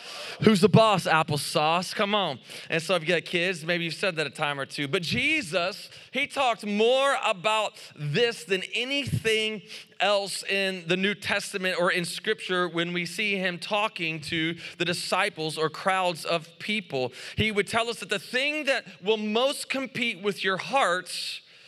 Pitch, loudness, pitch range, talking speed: 190 Hz, -26 LUFS, 170-215 Hz, 175 wpm